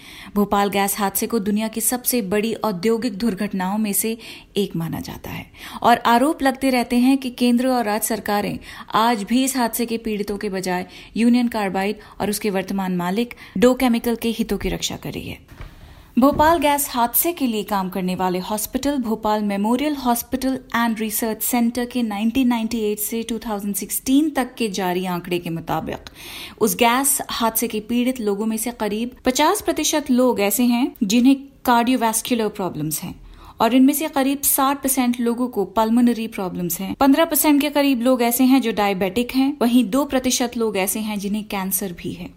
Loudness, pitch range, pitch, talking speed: -20 LUFS, 205-255 Hz, 230 Hz, 175 wpm